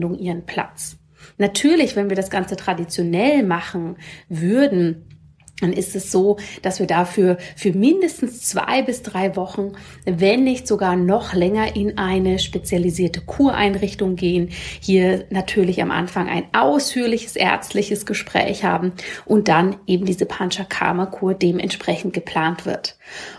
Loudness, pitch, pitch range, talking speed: -20 LUFS, 190 Hz, 180-205 Hz, 130 wpm